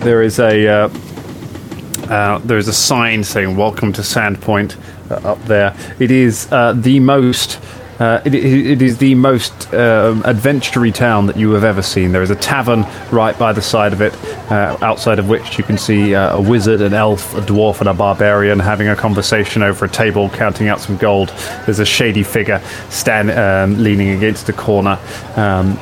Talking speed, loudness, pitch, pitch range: 195 wpm, -13 LUFS, 105 Hz, 100-115 Hz